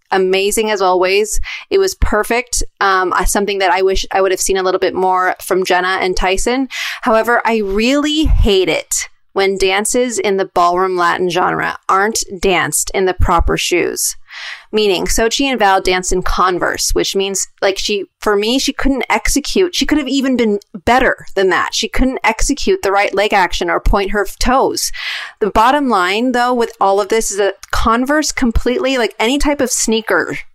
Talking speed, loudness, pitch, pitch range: 185 wpm, -14 LUFS, 210 Hz, 190-255 Hz